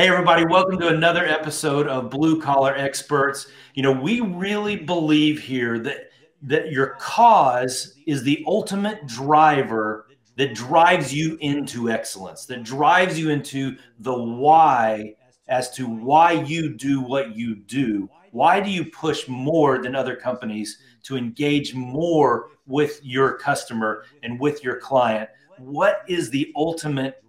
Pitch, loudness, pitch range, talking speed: 140 Hz, -21 LUFS, 125-160 Hz, 145 wpm